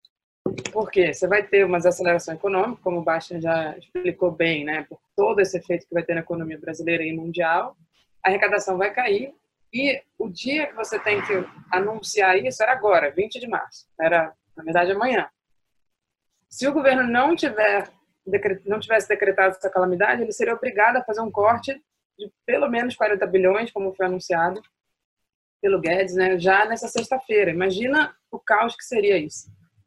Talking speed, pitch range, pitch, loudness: 175 wpm, 175-220 Hz, 195 Hz, -22 LUFS